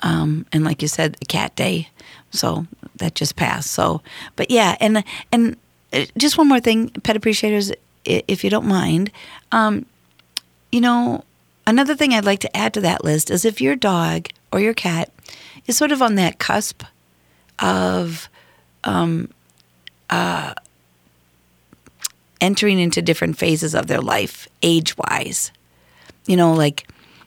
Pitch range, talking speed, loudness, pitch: 135-220 Hz, 145 wpm, -19 LUFS, 170 Hz